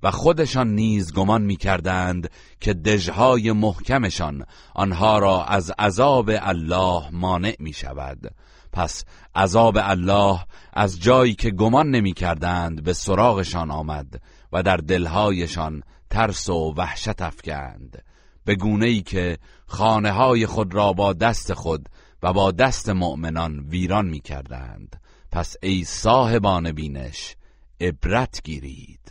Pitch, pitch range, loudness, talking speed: 95 Hz, 85-110 Hz, -21 LUFS, 125 wpm